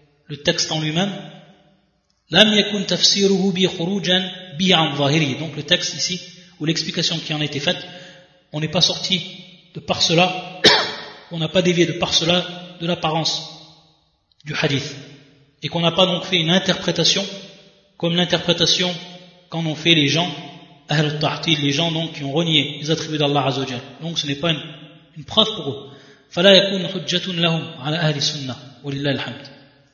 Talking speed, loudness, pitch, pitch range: 150 wpm, -18 LUFS, 165 Hz, 150-180 Hz